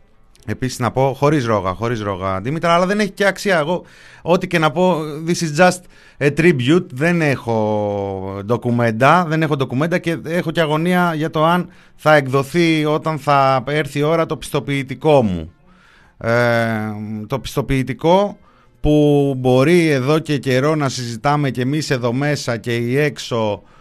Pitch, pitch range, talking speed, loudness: 145 Hz, 120-160 Hz, 160 wpm, -17 LUFS